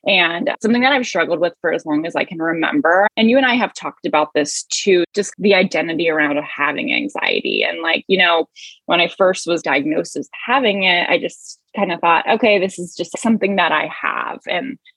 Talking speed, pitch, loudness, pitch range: 220 wpm, 185 Hz, -17 LUFS, 165-230 Hz